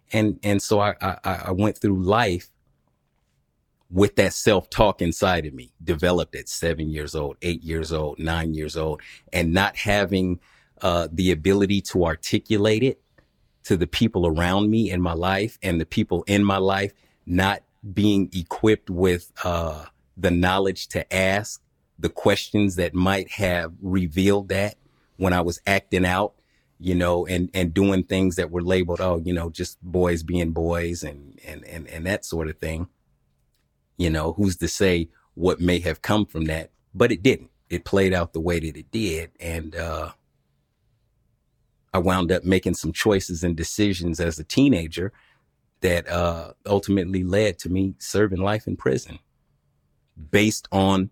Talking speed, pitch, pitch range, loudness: 165 wpm, 90 Hz, 85-100 Hz, -23 LUFS